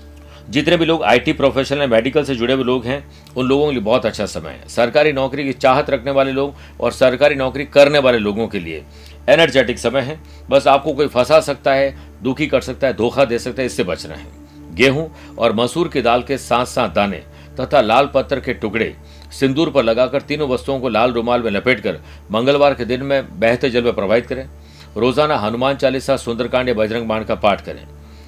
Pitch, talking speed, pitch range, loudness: 125 Hz, 210 wpm, 105-140 Hz, -16 LUFS